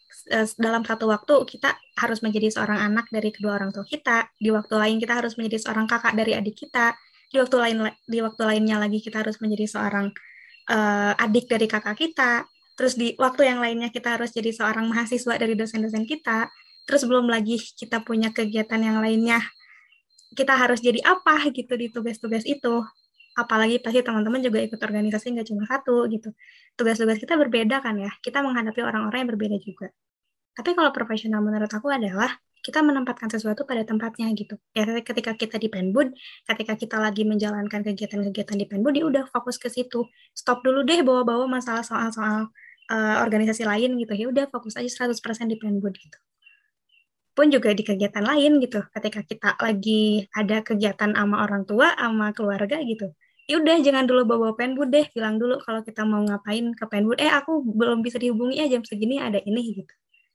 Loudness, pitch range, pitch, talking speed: -23 LUFS, 215-245 Hz, 230 Hz, 180 wpm